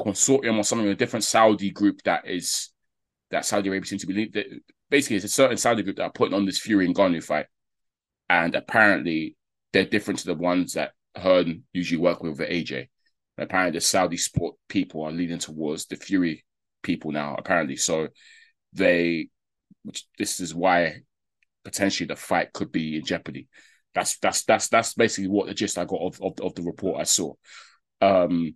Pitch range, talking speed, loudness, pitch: 85-110 Hz, 180 wpm, -24 LUFS, 100 Hz